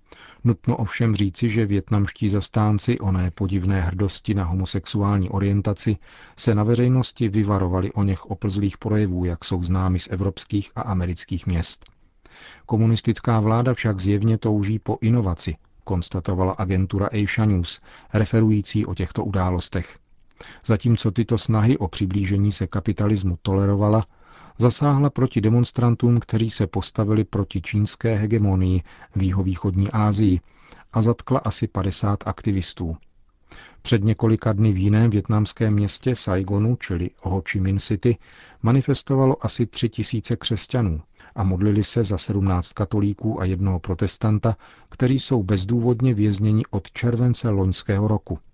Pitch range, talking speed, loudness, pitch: 95-115 Hz, 125 wpm, -22 LUFS, 105 Hz